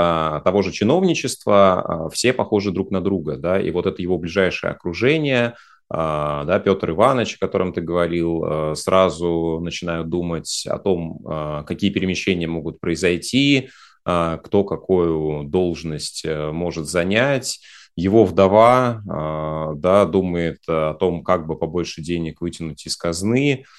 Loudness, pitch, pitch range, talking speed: -20 LUFS, 85 Hz, 80-95 Hz, 125 wpm